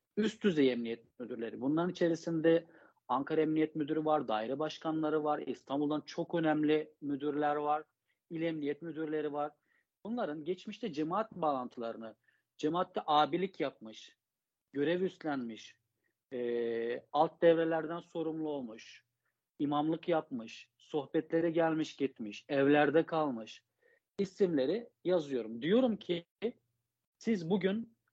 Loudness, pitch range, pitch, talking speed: -34 LUFS, 145-170 Hz, 155 Hz, 105 wpm